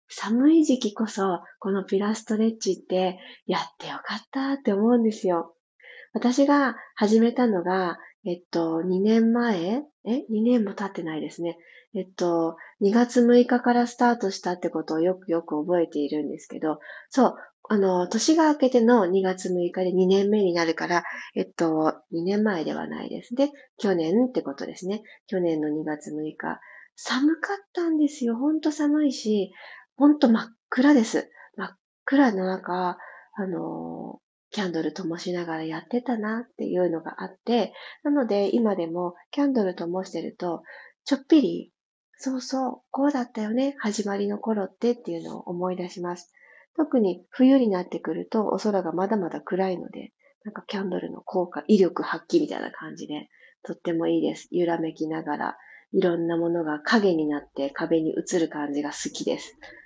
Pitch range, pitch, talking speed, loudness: 175-240 Hz, 195 Hz, 320 characters per minute, -25 LUFS